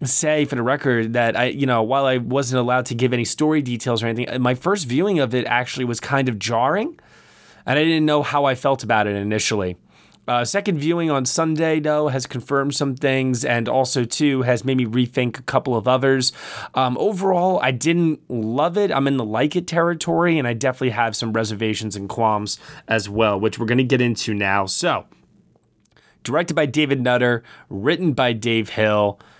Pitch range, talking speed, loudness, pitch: 115-145 Hz, 200 wpm, -20 LUFS, 125 Hz